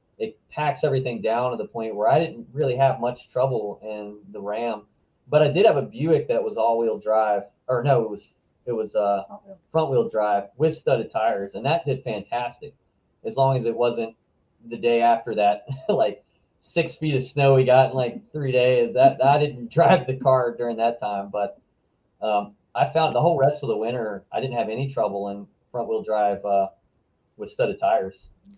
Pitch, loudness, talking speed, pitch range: 120 Hz, -23 LUFS, 205 wpm, 110-145 Hz